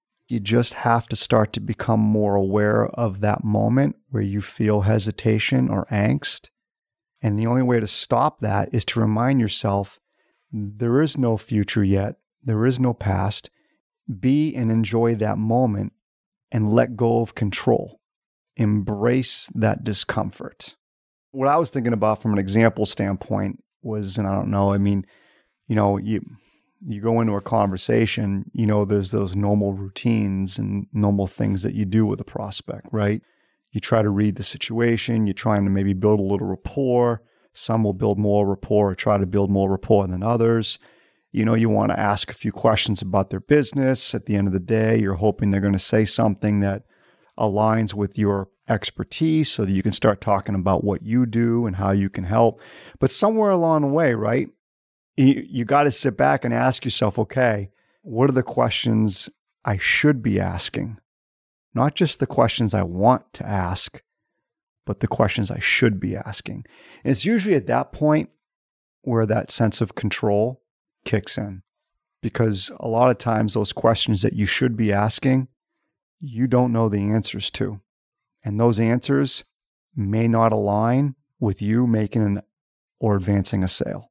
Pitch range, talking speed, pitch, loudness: 100-120 Hz, 175 wpm, 110 Hz, -21 LUFS